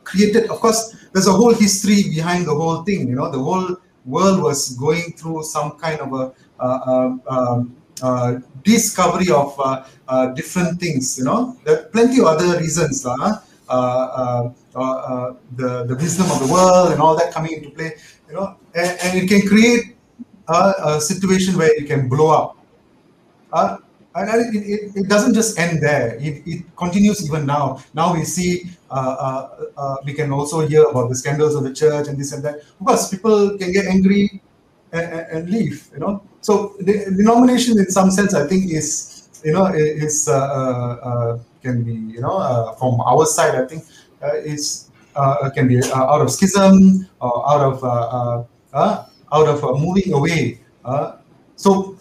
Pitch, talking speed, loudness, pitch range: 155 Hz, 190 wpm, -17 LUFS, 135-190 Hz